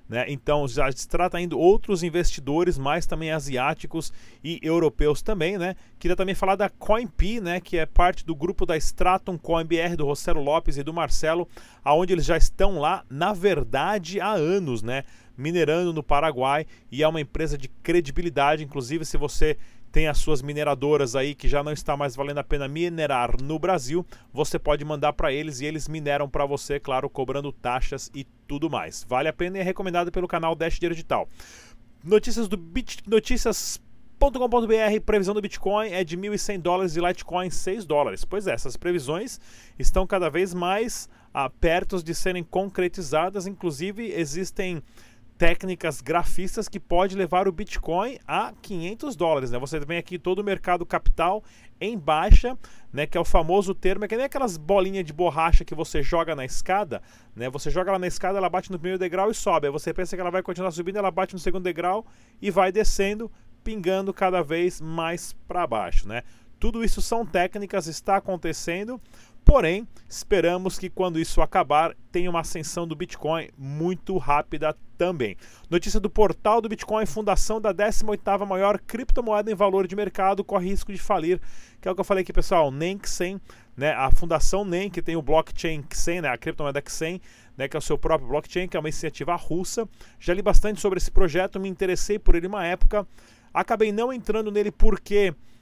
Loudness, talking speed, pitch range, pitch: -26 LUFS, 185 wpm, 150-195 Hz, 175 Hz